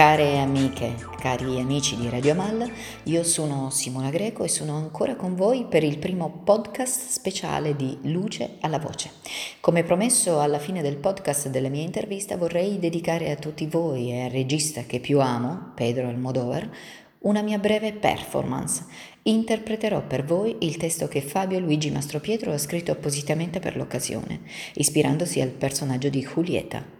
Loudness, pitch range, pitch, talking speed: -25 LUFS, 135-190 Hz, 155 Hz, 160 wpm